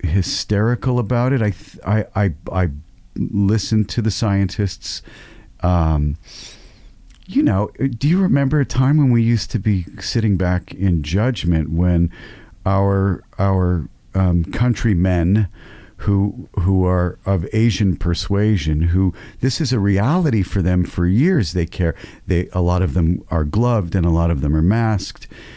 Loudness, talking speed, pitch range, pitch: -19 LUFS, 155 wpm, 90-110 Hz, 100 Hz